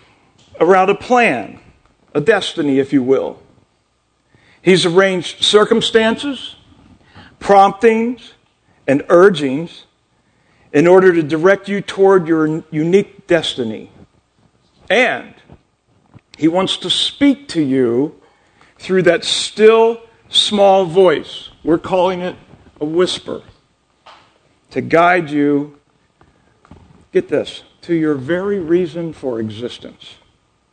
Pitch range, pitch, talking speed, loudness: 155-200 Hz, 180 Hz, 100 wpm, -14 LUFS